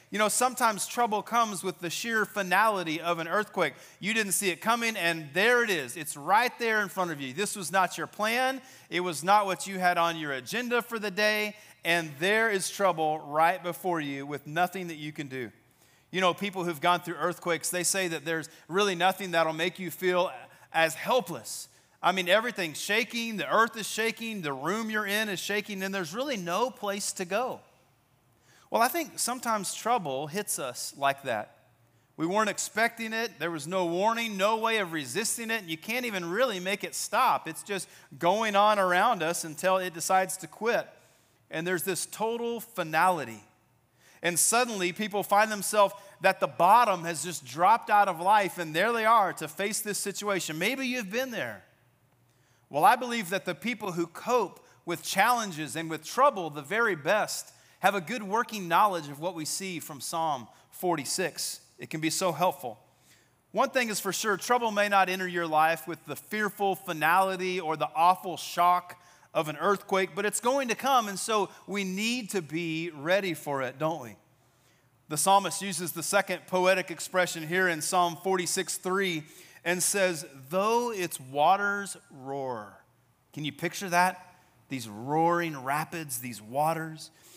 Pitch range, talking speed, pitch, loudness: 165-210 Hz, 185 wpm, 185 Hz, -28 LUFS